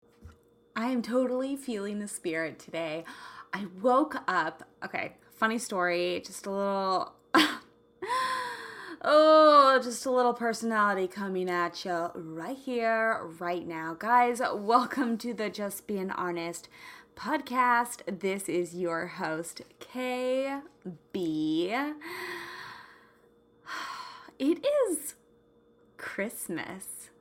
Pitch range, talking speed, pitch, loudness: 180-275 Hz, 95 wpm, 230 Hz, -29 LUFS